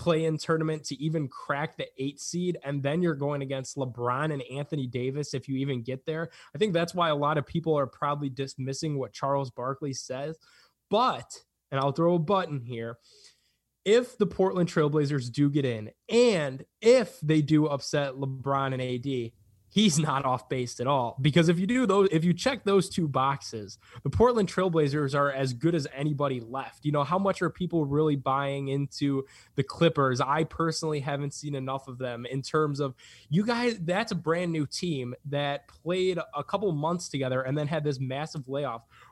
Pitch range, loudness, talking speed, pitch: 135-165 Hz, -28 LUFS, 195 wpm, 145 Hz